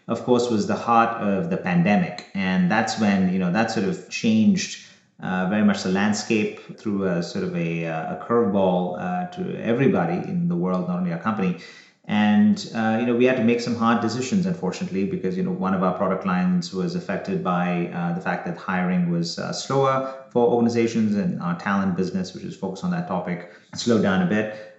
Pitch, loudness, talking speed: 130 Hz, -23 LUFS, 210 wpm